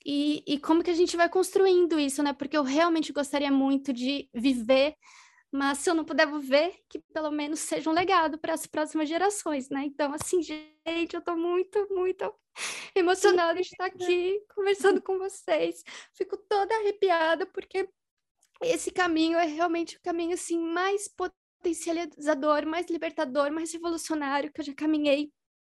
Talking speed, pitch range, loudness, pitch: 165 wpm, 300-370 Hz, -28 LUFS, 335 Hz